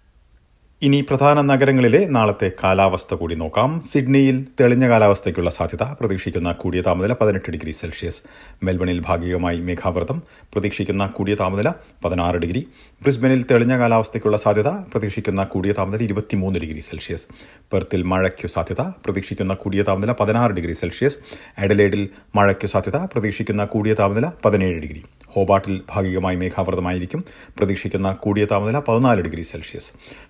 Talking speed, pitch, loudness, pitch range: 120 wpm, 100 Hz, -20 LUFS, 90-110 Hz